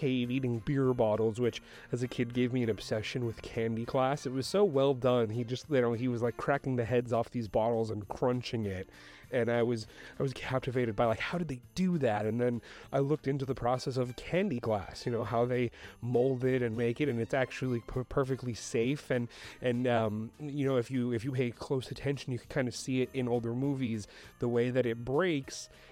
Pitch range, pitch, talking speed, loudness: 115-135 Hz, 125 Hz, 230 wpm, -32 LUFS